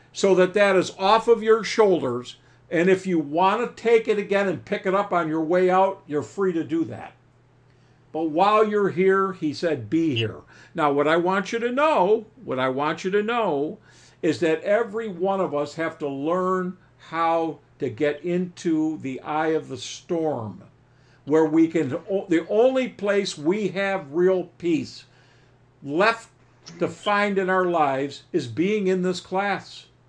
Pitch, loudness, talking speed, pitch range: 175 Hz, -23 LUFS, 180 wpm, 145-195 Hz